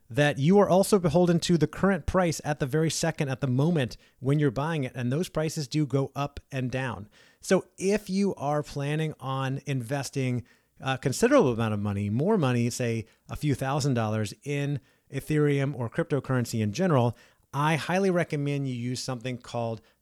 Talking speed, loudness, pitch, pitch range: 180 wpm, -27 LUFS, 140 Hz, 125-155 Hz